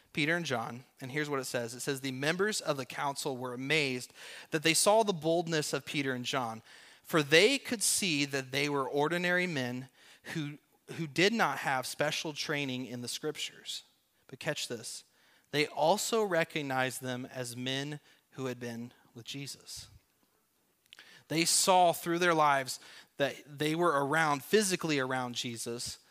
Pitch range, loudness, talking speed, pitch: 130-165 Hz, -31 LUFS, 165 wpm, 145 Hz